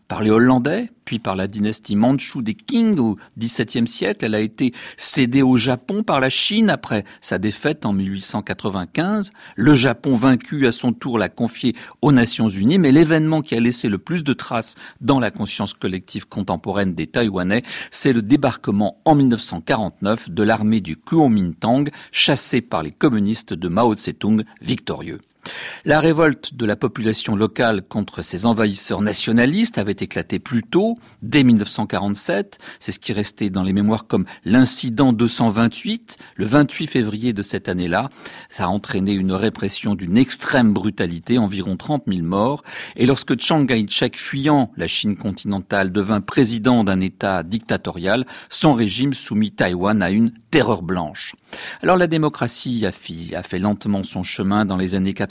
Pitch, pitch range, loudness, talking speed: 115 Hz, 100-135 Hz, -19 LUFS, 160 wpm